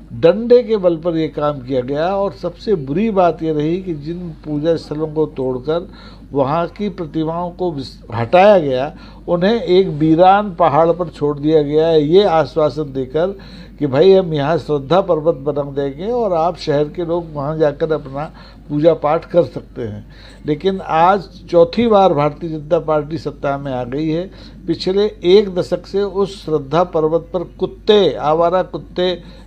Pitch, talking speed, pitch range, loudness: 165 Hz, 165 wpm, 150-180 Hz, -16 LUFS